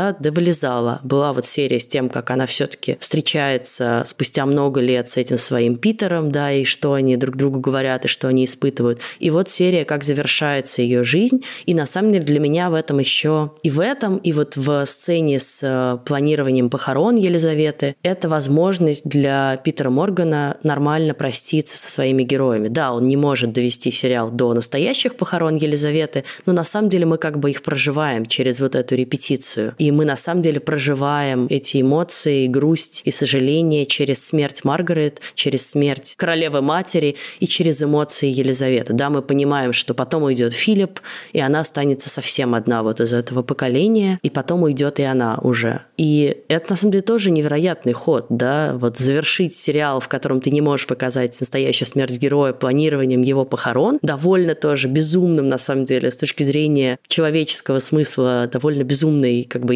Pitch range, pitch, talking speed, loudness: 130-155 Hz, 145 Hz, 175 wpm, -18 LUFS